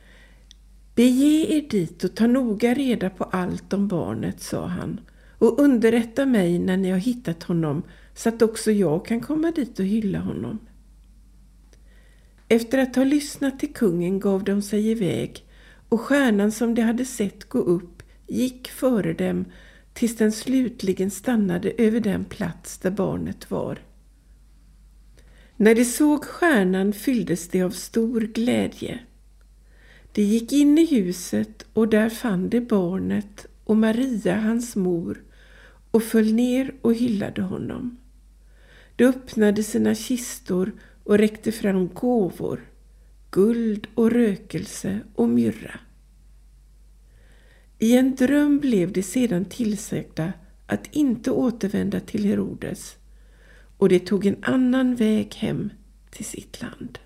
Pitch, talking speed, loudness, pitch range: 215 Hz, 135 wpm, -22 LUFS, 185-245 Hz